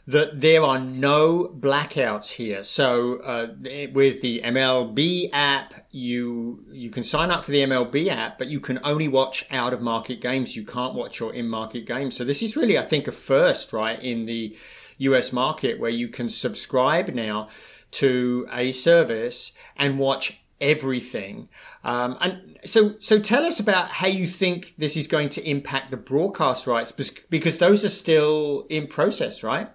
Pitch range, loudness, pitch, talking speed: 125-155 Hz, -23 LUFS, 135 Hz, 175 wpm